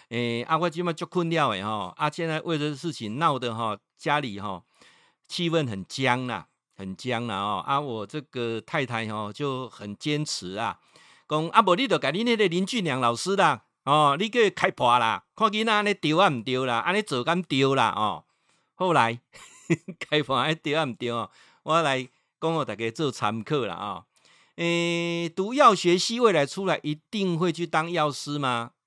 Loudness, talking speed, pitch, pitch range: -25 LUFS, 255 characters per minute, 150 Hz, 120-175 Hz